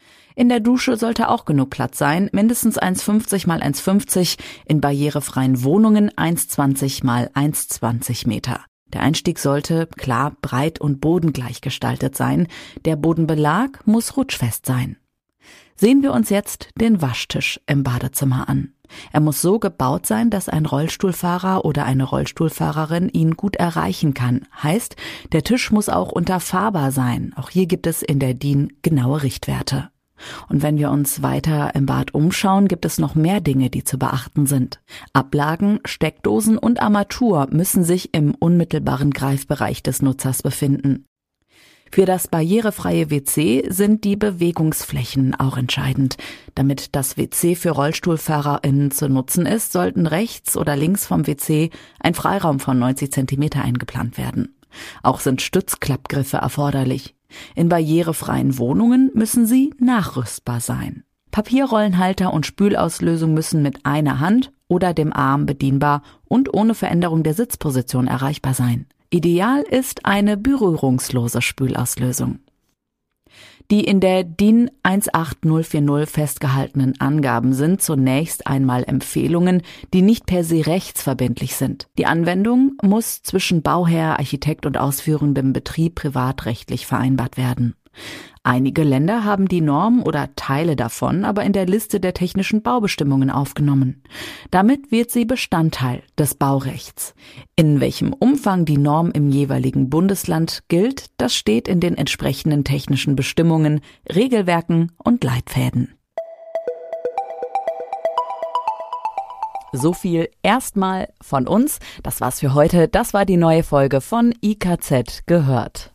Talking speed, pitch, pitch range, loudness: 130 wpm, 160 Hz, 135-195 Hz, -19 LUFS